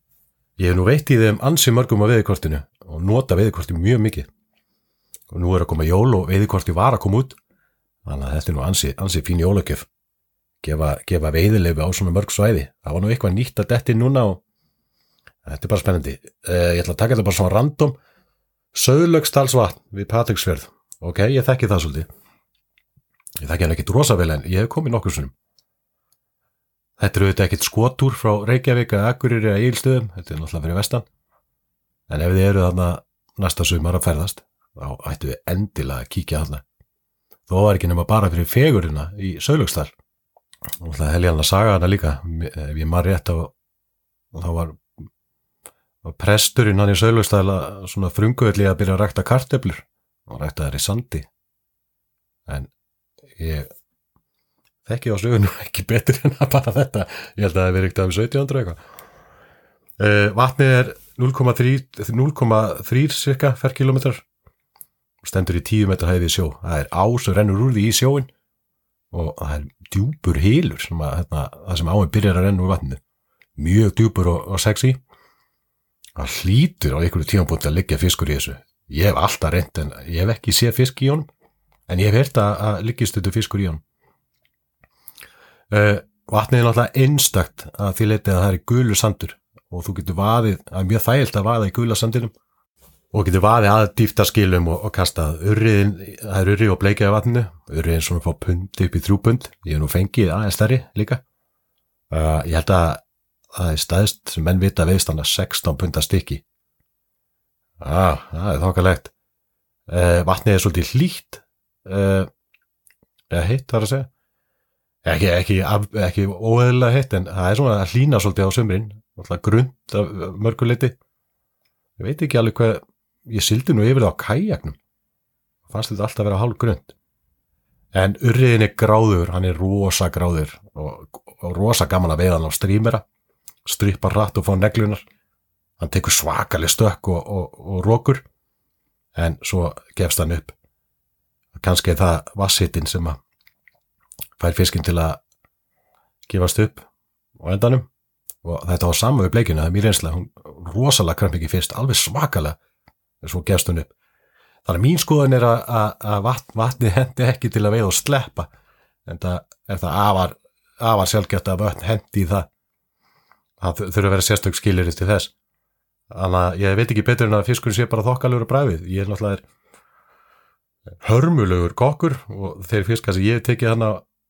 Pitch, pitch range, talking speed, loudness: 100 Hz, 85-115 Hz, 170 wpm, -19 LUFS